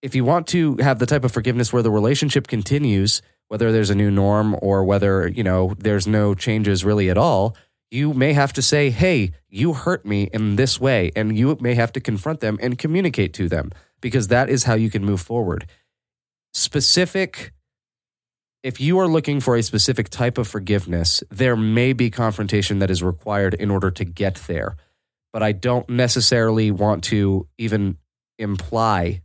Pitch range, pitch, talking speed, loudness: 100-130 Hz, 110 Hz, 185 wpm, -19 LUFS